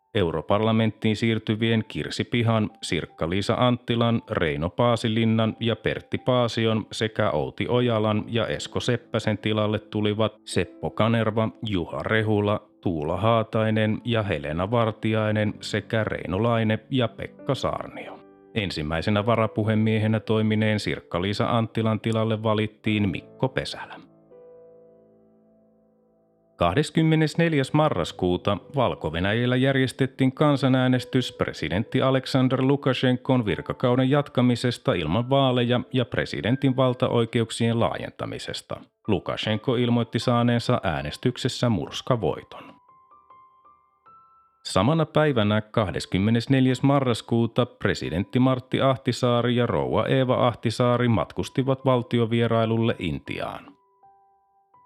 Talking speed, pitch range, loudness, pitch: 85 wpm, 110-130 Hz, -24 LUFS, 115 Hz